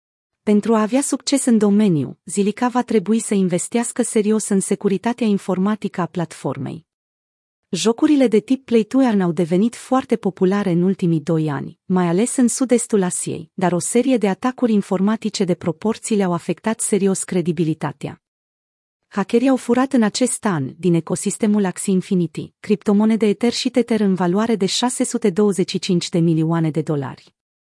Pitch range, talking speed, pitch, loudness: 175-230 Hz, 150 wpm, 200 Hz, -19 LUFS